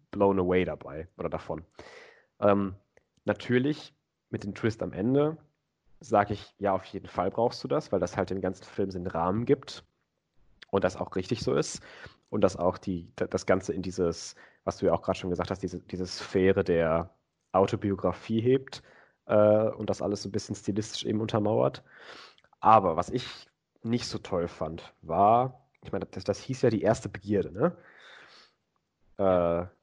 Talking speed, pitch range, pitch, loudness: 175 wpm, 90-115 Hz, 100 Hz, -29 LUFS